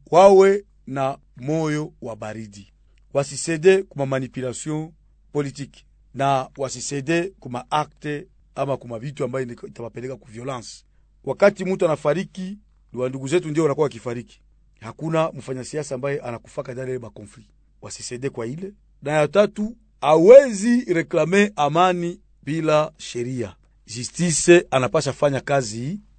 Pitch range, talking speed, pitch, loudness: 125-170 Hz, 110 wpm, 140 Hz, -21 LUFS